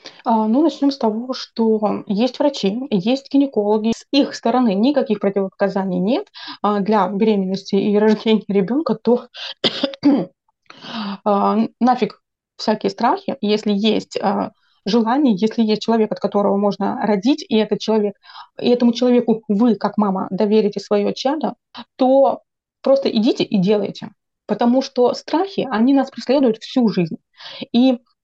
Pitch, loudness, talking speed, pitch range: 225 Hz, -18 LUFS, 125 wpm, 205-260 Hz